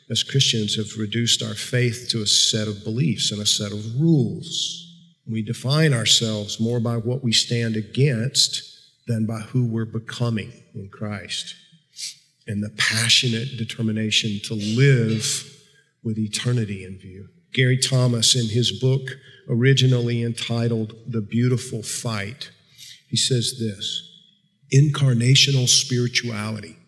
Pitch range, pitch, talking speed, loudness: 110-135 Hz, 120 Hz, 125 wpm, -21 LUFS